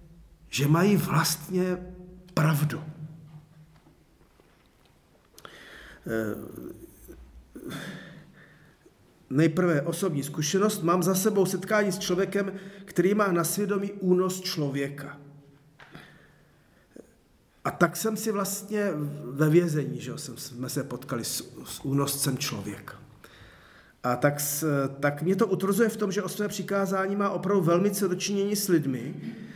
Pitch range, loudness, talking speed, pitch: 145-195 Hz, -27 LUFS, 110 wpm, 170 Hz